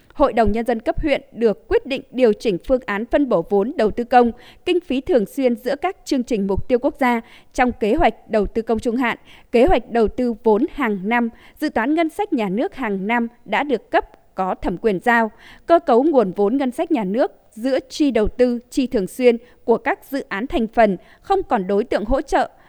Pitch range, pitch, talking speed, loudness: 225-280 Hz, 245 Hz, 235 wpm, -20 LUFS